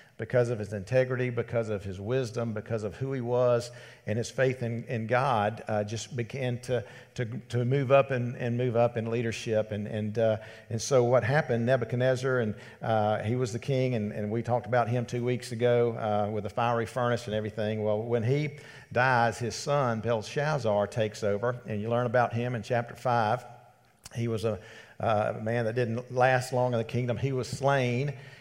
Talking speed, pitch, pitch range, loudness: 200 wpm, 120 Hz, 110-125 Hz, -29 LUFS